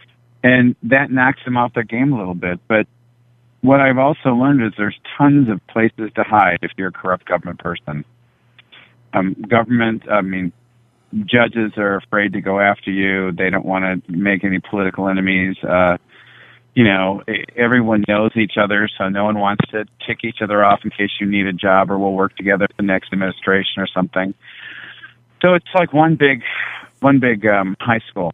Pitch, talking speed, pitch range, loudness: 105 Hz, 185 wpm, 95-120 Hz, -16 LUFS